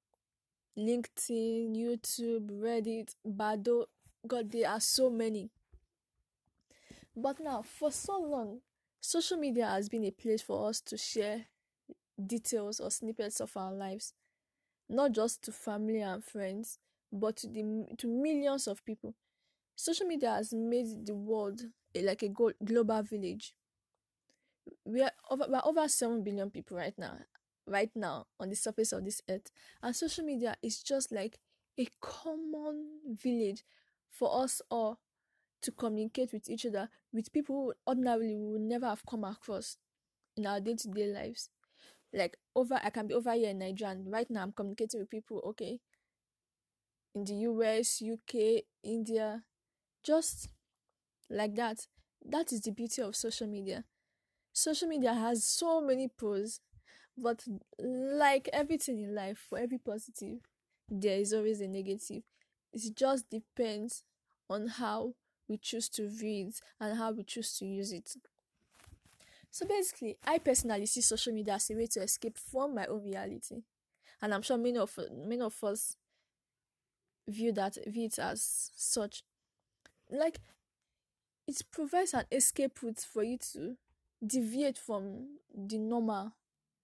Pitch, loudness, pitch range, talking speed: 225 Hz, -35 LUFS, 215-255 Hz, 150 wpm